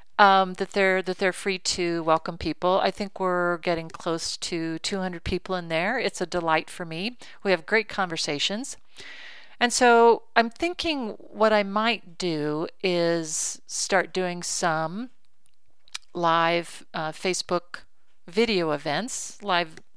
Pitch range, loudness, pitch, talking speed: 170-205 Hz, -25 LUFS, 185 Hz, 140 wpm